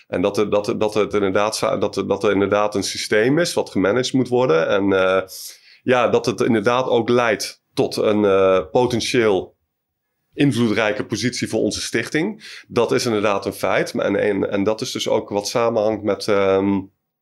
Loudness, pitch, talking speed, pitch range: -19 LUFS, 105 Hz, 185 wpm, 100-120 Hz